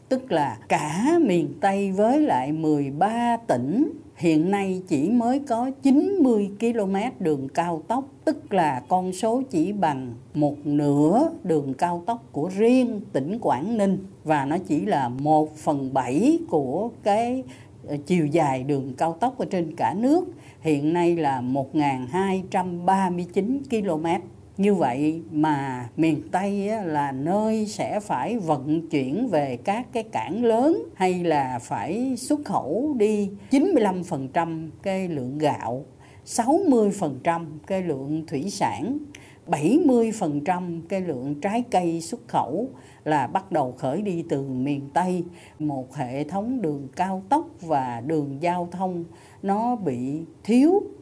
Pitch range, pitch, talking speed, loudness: 150-225 Hz, 175 Hz, 140 wpm, -24 LUFS